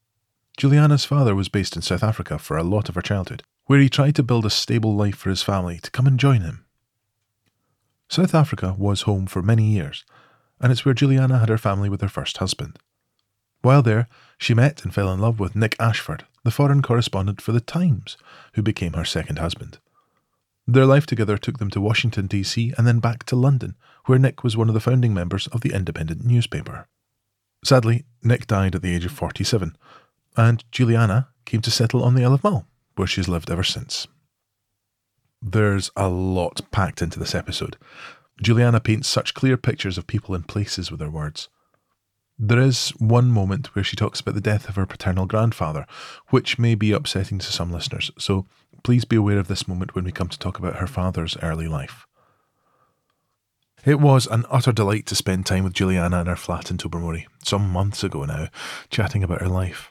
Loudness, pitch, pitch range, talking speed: -21 LUFS, 110 Hz, 95-125 Hz, 195 wpm